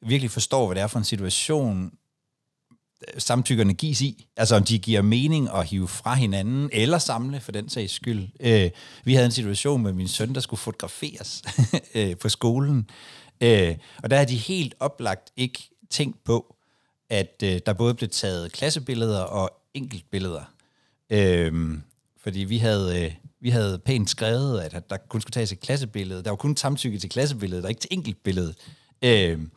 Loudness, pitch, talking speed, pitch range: -24 LUFS, 115 Hz, 175 wpm, 100-130 Hz